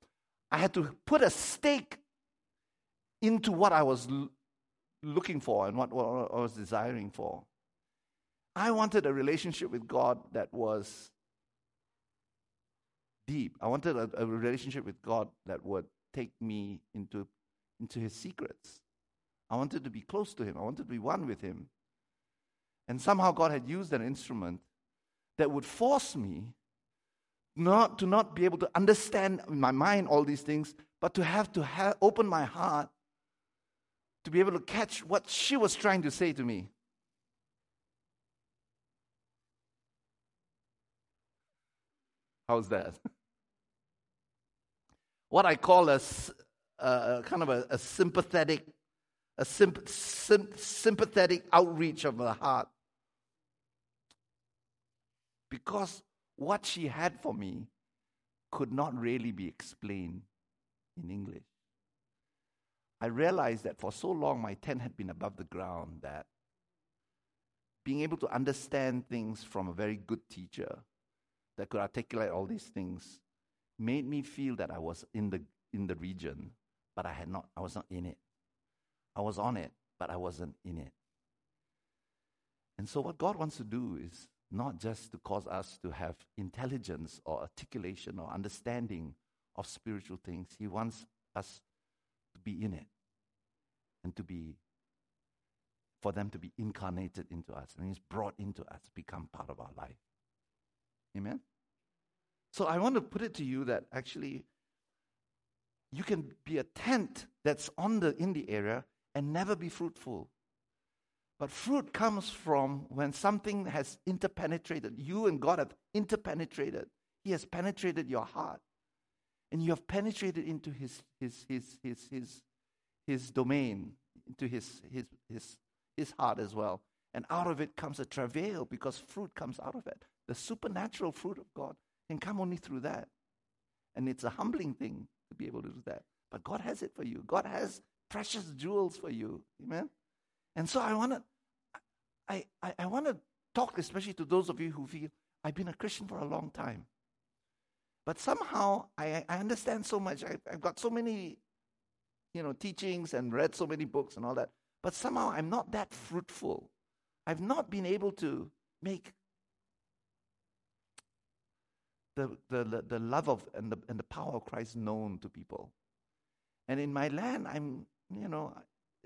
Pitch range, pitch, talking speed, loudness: 110-180 Hz, 135 Hz, 155 wpm, -34 LUFS